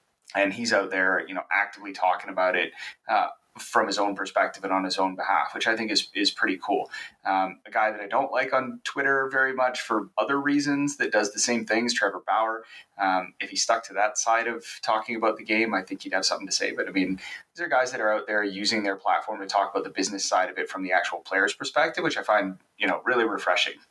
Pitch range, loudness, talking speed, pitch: 95-120 Hz, -25 LUFS, 250 wpm, 110 Hz